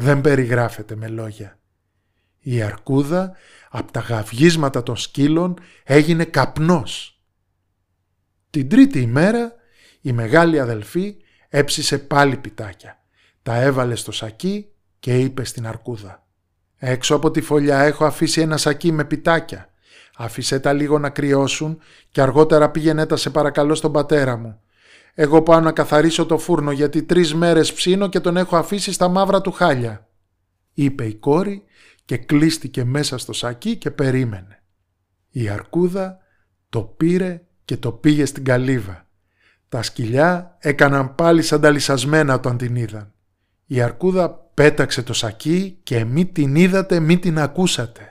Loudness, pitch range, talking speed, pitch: -18 LUFS, 115-160 Hz, 140 wpm, 140 Hz